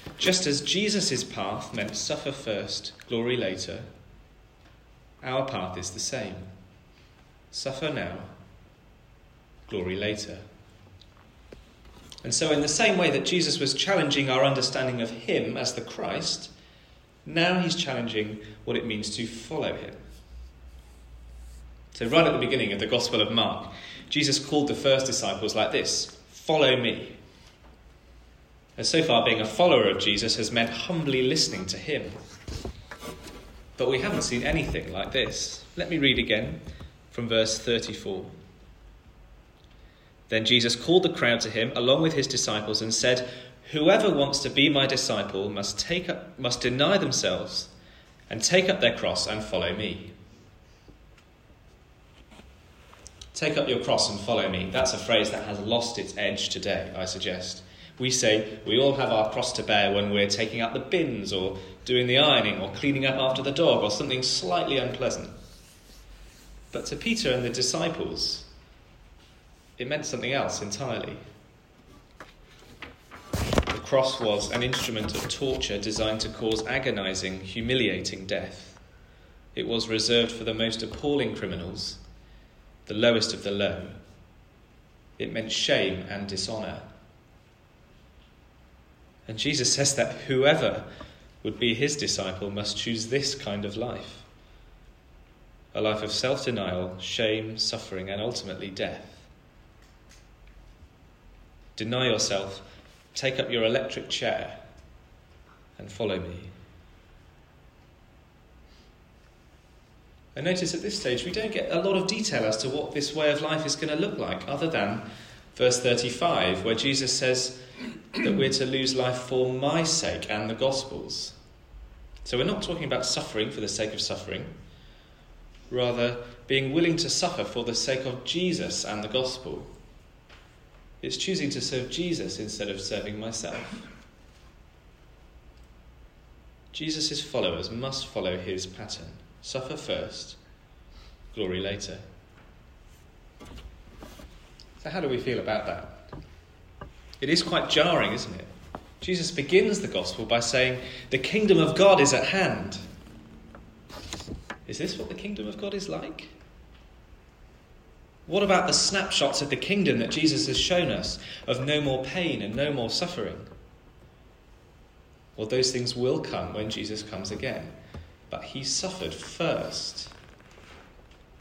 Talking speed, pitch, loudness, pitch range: 140 wpm, 115 Hz, -26 LUFS, 95-135 Hz